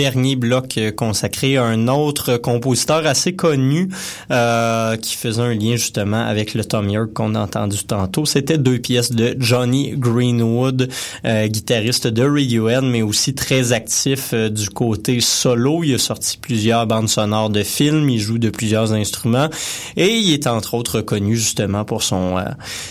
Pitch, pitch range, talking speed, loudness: 120 Hz, 110-130 Hz, 170 wpm, -17 LUFS